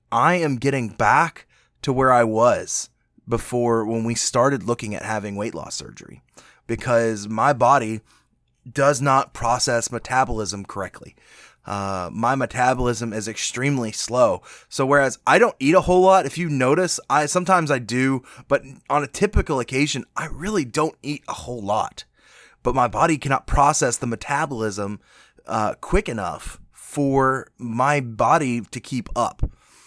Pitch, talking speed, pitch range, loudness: 125 Hz, 150 wpm, 115-140 Hz, -21 LUFS